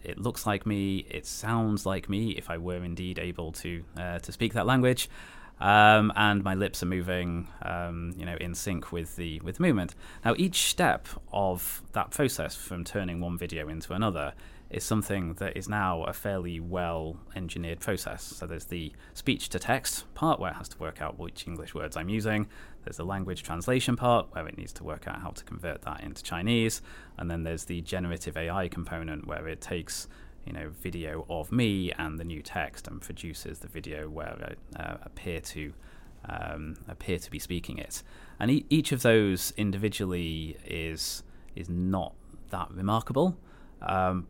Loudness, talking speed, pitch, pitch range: -31 LUFS, 185 wpm, 90 Hz, 85-100 Hz